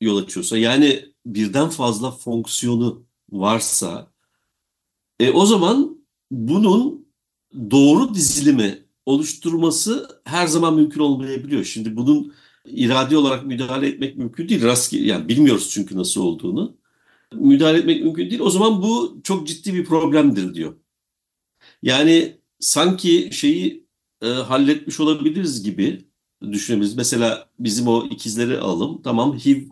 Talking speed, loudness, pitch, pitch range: 115 wpm, -18 LUFS, 140 Hz, 120-185 Hz